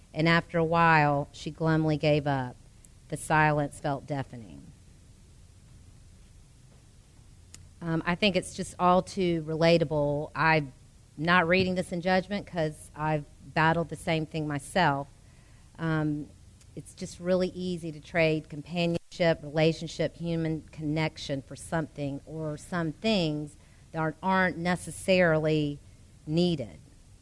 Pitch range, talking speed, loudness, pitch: 140-170 Hz, 115 wpm, -28 LUFS, 155 Hz